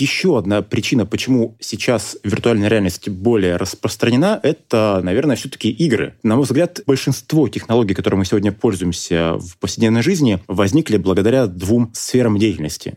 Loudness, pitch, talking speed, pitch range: -17 LUFS, 110 Hz, 140 wpm, 100-120 Hz